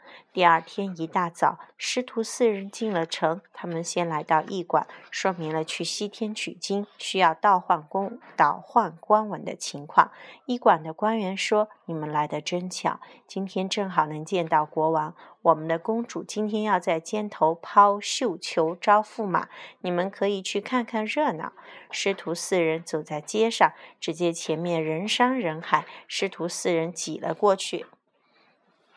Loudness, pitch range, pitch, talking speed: -26 LUFS, 165-215 Hz, 185 Hz, 230 characters per minute